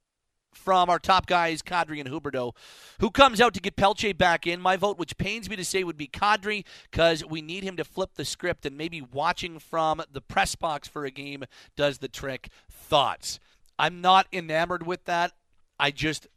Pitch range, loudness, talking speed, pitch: 145-185 Hz, -26 LUFS, 200 wpm, 170 Hz